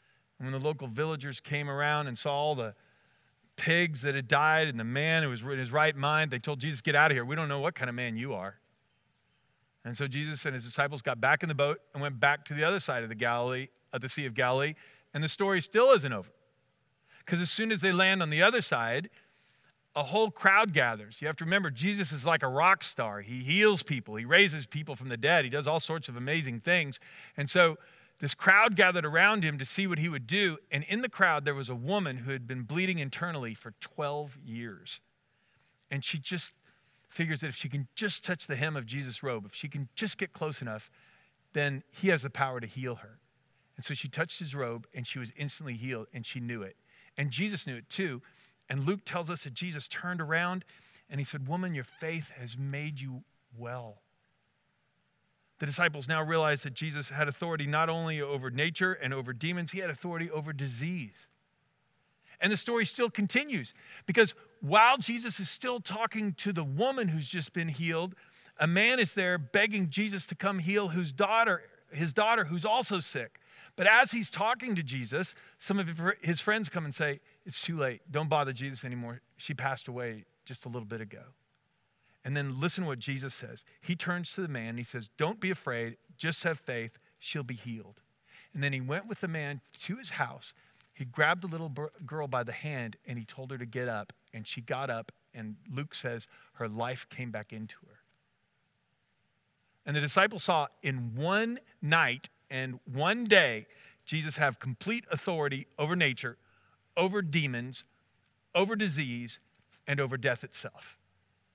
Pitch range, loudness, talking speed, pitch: 130-175 Hz, -30 LUFS, 200 wpm, 150 Hz